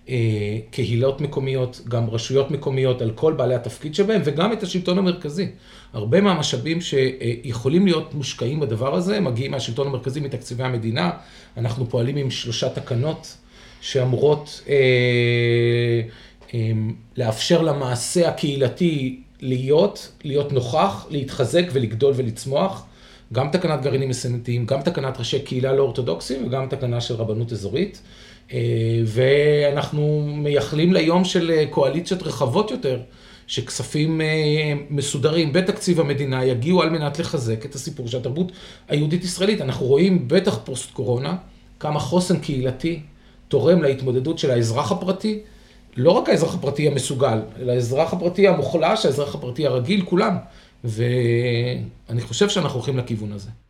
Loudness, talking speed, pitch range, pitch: -21 LUFS, 125 wpm, 125-160 Hz, 135 Hz